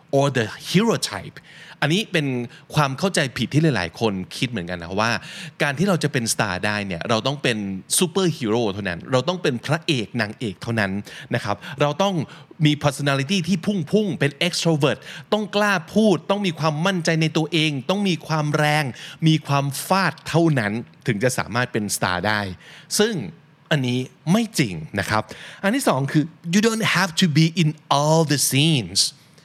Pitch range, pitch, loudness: 120-175 Hz, 150 Hz, -21 LUFS